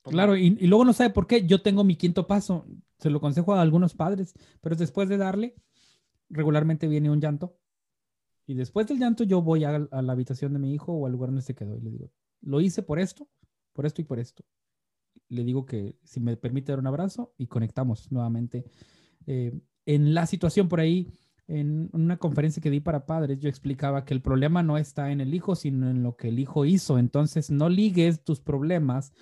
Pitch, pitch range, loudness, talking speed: 150 Hz, 135-180 Hz, -26 LUFS, 215 wpm